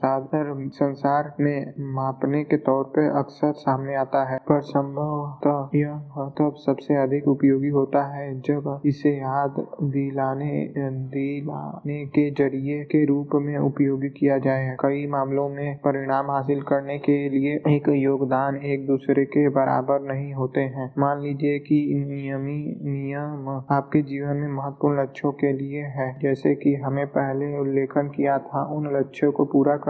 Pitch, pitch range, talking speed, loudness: 140 Hz, 135-145 Hz, 145 wpm, -24 LUFS